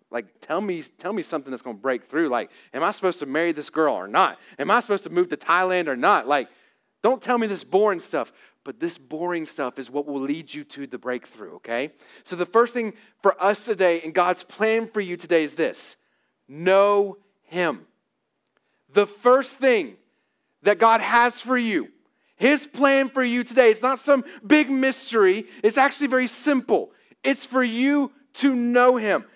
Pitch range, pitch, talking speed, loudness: 175-255 Hz, 210 Hz, 195 wpm, -22 LUFS